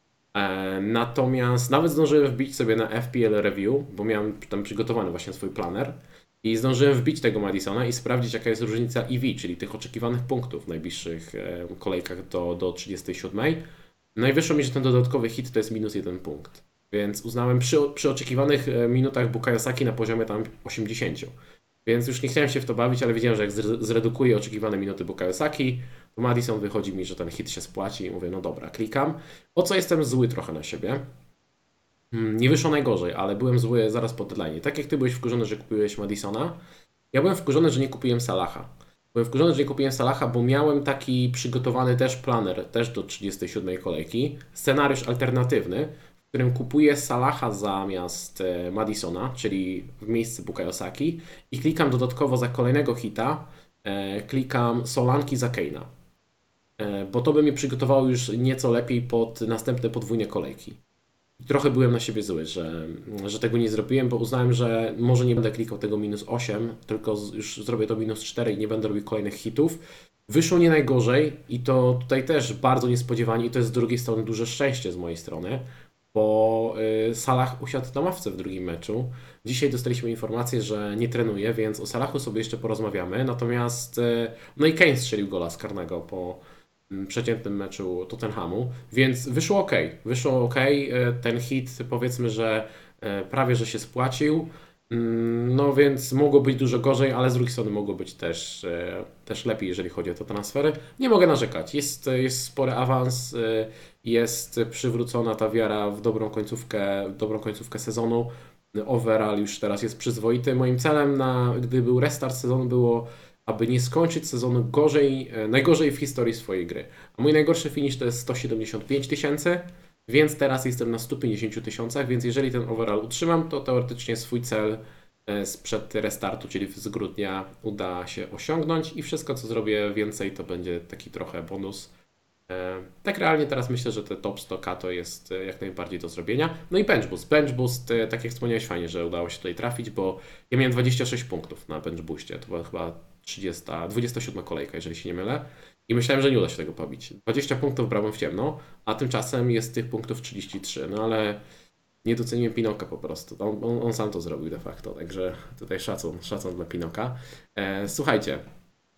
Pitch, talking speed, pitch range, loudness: 120 Hz, 175 wpm, 105-130 Hz, -26 LUFS